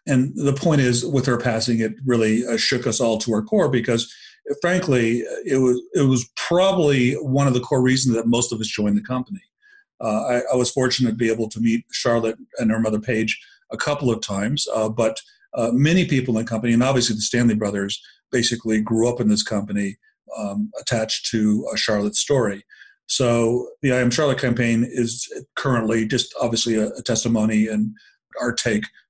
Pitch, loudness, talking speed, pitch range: 120 Hz, -21 LUFS, 190 wpm, 110-130 Hz